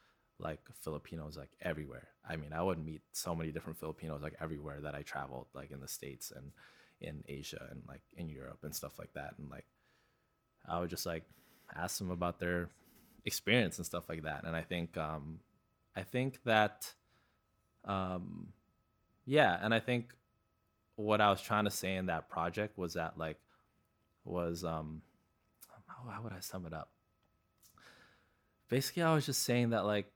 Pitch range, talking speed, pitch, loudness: 80-105 Hz, 175 wpm, 90 Hz, -38 LUFS